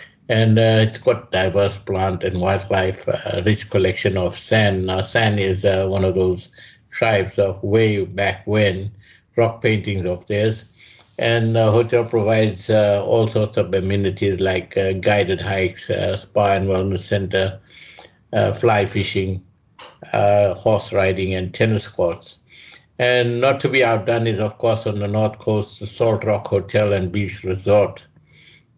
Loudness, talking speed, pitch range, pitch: -19 LUFS, 155 wpm, 95-110 Hz, 100 Hz